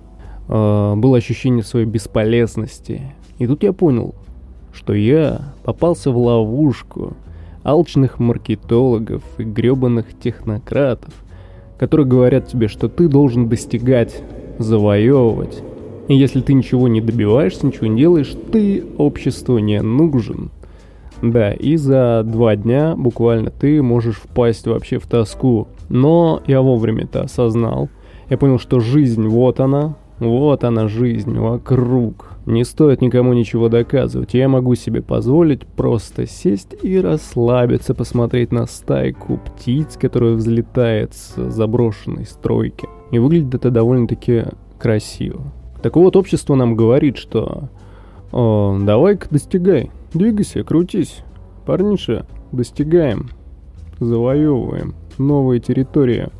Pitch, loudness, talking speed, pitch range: 120 Hz, -16 LUFS, 115 wpm, 110-135 Hz